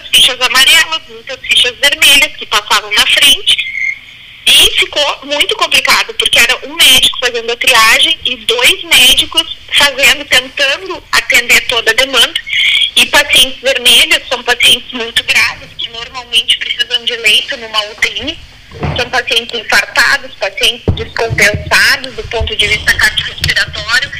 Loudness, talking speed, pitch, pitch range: -8 LUFS, 130 wpm, 260 Hz, 235-300 Hz